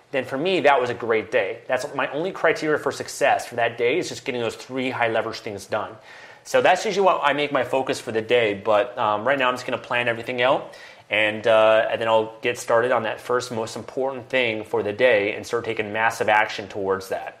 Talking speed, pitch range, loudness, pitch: 240 wpm, 110-135 Hz, -22 LUFS, 120 Hz